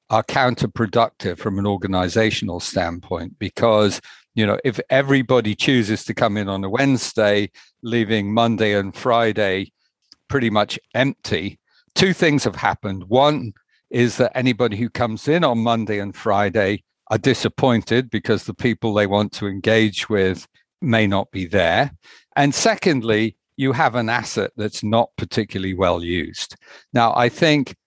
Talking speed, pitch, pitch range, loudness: 145 wpm, 110 Hz, 100-125 Hz, -20 LUFS